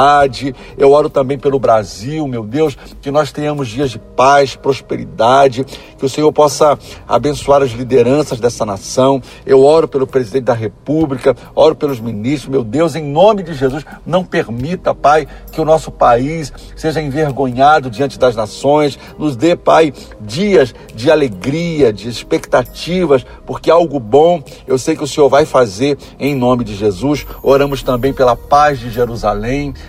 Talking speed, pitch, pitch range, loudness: 155 wpm, 140 Hz, 125-150 Hz, -13 LUFS